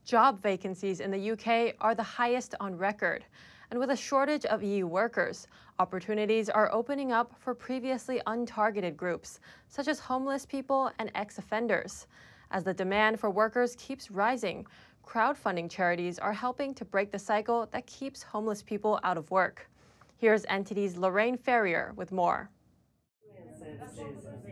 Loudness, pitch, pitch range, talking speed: -31 LUFS, 215 Hz, 195-245 Hz, 145 wpm